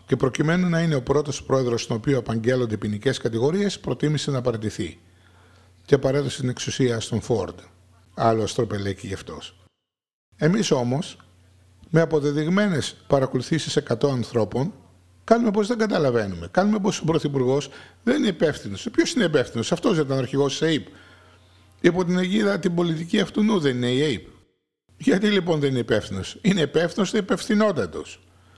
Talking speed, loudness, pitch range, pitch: 155 wpm, -23 LUFS, 105-170 Hz, 135 Hz